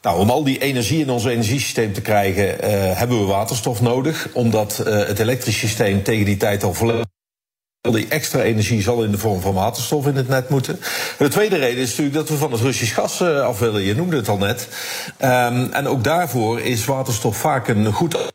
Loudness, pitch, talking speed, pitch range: -19 LUFS, 120 Hz, 215 wpm, 110-135 Hz